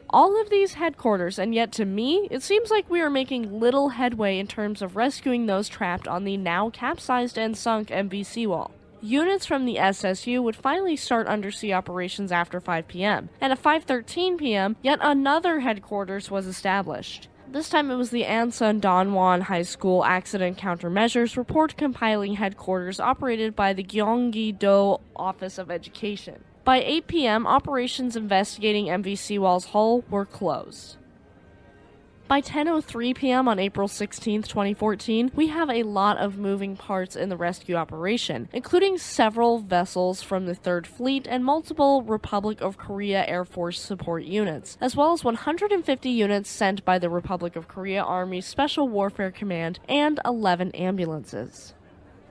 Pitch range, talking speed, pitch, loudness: 190-255 Hz, 150 wpm, 210 Hz, -25 LUFS